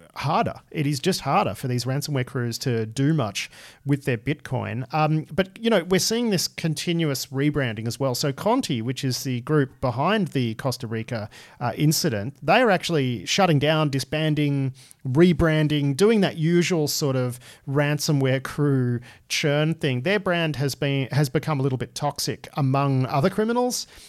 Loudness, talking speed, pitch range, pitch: -23 LUFS, 165 wpm, 130-160 Hz, 145 Hz